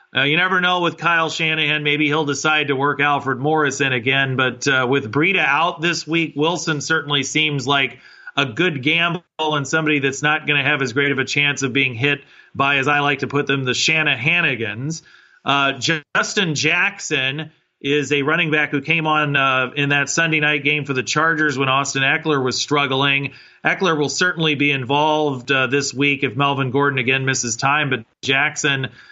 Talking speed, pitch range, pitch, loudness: 195 wpm, 135-155 Hz, 145 Hz, -18 LUFS